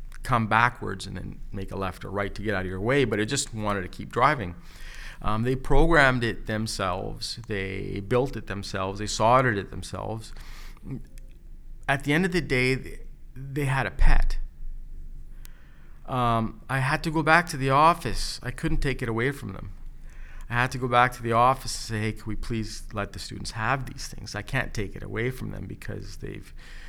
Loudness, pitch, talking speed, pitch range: -26 LUFS, 110 Hz, 200 wpm, 95-130 Hz